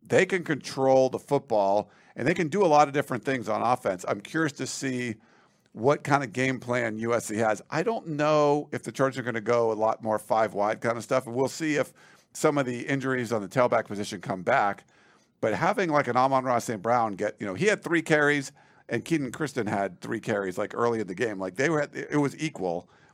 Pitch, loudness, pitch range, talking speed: 130 Hz, -27 LUFS, 115-145 Hz, 240 wpm